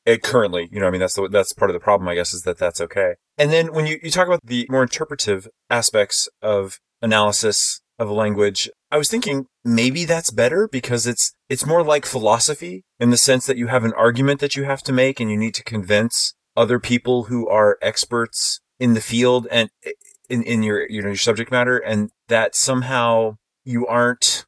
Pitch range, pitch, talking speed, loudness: 110-140 Hz, 120 Hz, 215 wpm, -19 LUFS